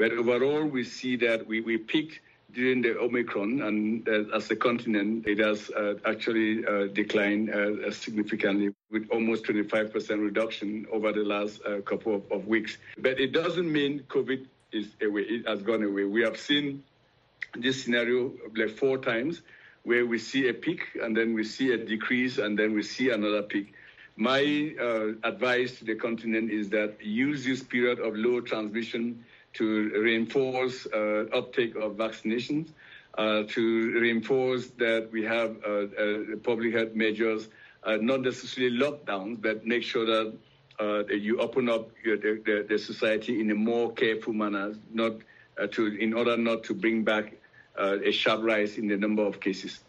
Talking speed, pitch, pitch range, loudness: 170 wpm, 110 Hz, 105-120 Hz, -28 LUFS